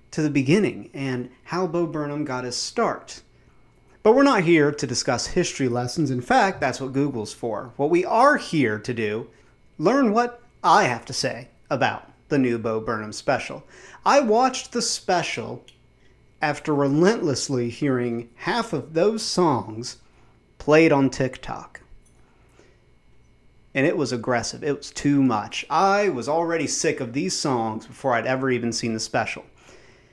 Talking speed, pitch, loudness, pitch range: 155 wpm, 135 Hz, -22 LUFS, 120-165 Hz